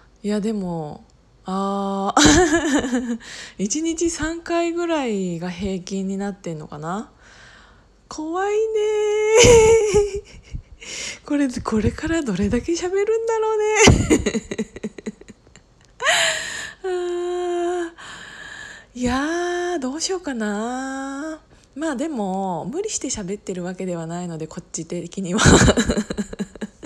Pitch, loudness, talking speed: 260 Hz, -20 LUFS, 180 characters per minute